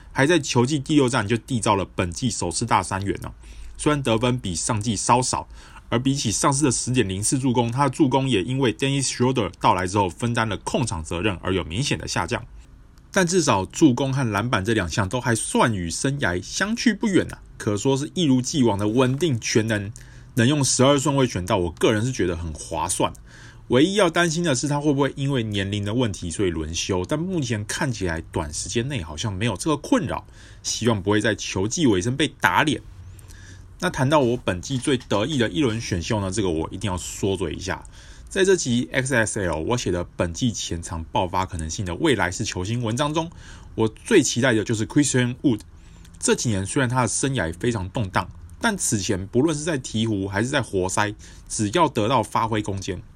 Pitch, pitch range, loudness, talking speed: 115 Hz, 95-130 Hz, -22 LUFS, 330 characters per minute